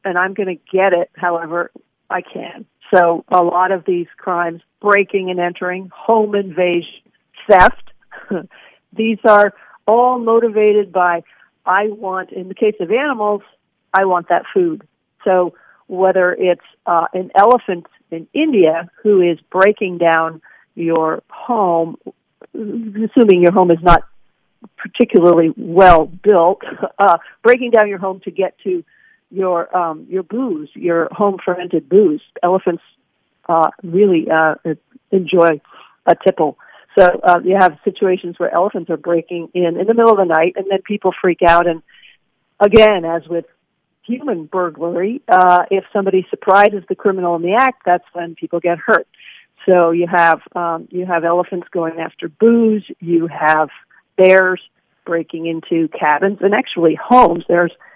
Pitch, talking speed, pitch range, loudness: 185 Hz, 150 wpm, 170-205 Hz, -15 LUFS